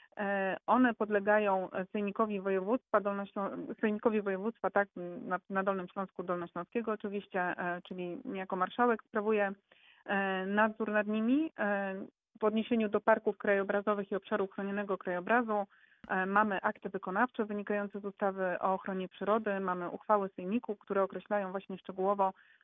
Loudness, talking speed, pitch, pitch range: -33 LUFS, 120 wpm, 200 Hz, 190-215 Hz